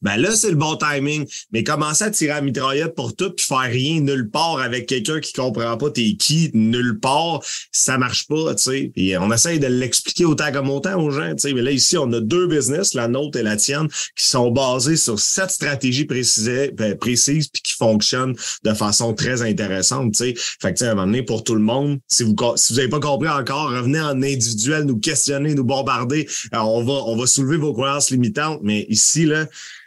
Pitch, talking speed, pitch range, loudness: 135 Hz, 225 wpm, 120-150 Hz, -18 LUFS